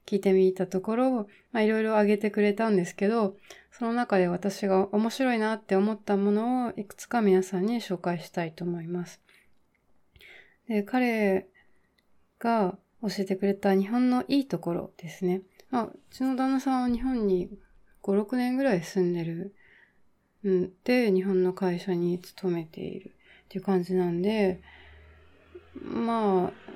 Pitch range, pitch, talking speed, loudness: 185-225 Hz, 200 Hz, 285 characters per minute, -27 LUFS